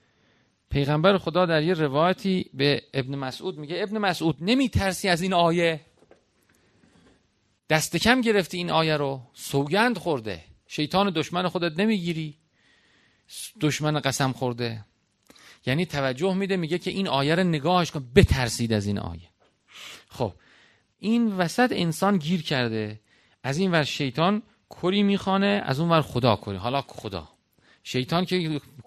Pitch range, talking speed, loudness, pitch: 135-185 Hz, 135 wpm, -25 LUFS, 160 Hz